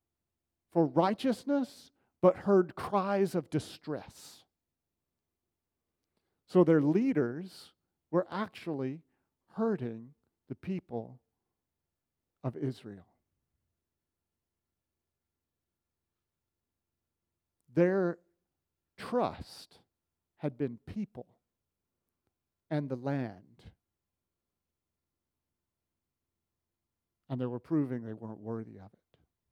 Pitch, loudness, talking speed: 105 Hz, -32 LUFS, 70 wpm